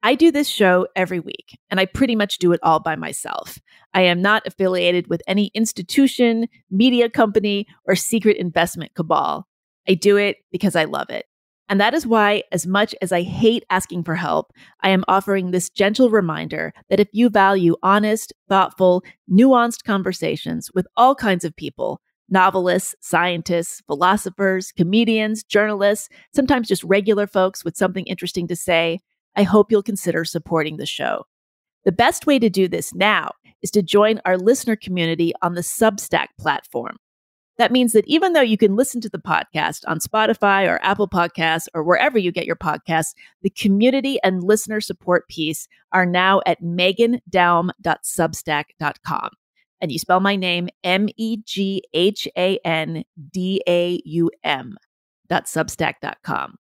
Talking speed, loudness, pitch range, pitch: 160 wpm, -19 LUFS, 175-215 Hz, 190 Hz